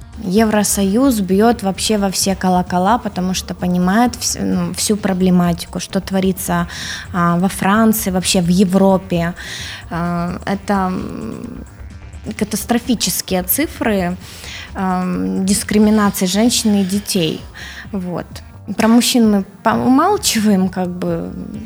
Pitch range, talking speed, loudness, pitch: 180-215 Hz, 90 wpm, -16 LUFS, 195 Hz